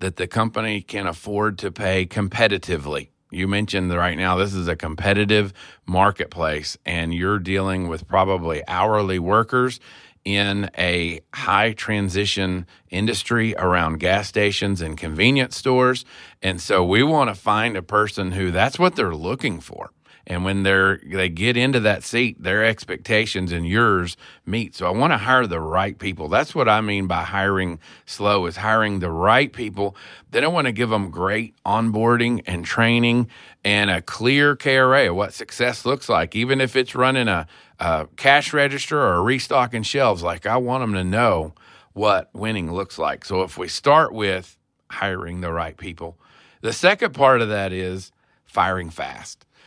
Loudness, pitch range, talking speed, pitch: -20 LUFS, 90-115 Hz, 170 wpm, 100 Hz